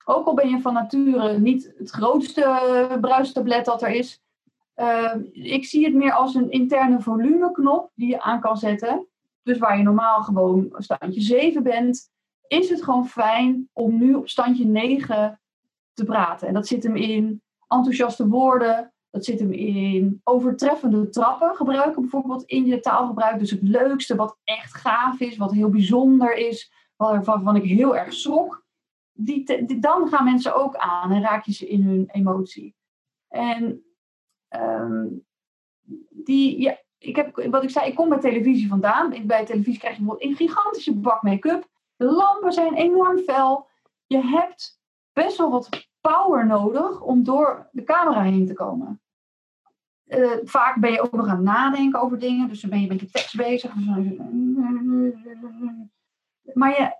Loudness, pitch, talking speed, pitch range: -21 LUFS, 250 Hz, 170 wpm, 220-275 Hz